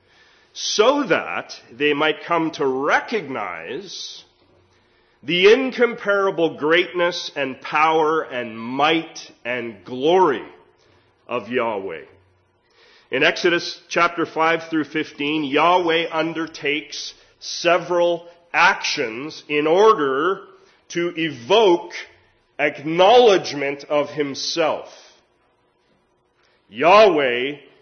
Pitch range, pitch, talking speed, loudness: 145-175 Hz, 160 Hz, 80 wpm, -19 LUFS